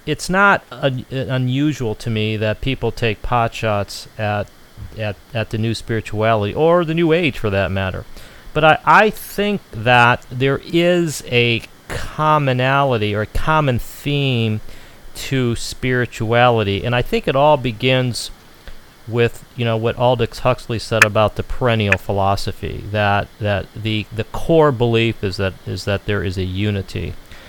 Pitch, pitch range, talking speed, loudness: 115 Hz, 105-130 Hz, 150 wpm, -18 LUFS